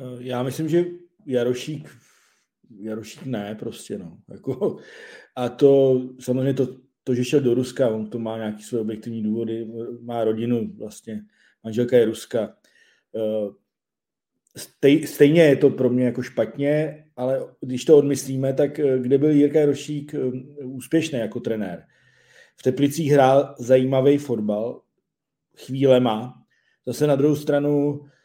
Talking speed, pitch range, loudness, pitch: 125 wpm, 115-145 Hz, -21 LUFS, 130 Hz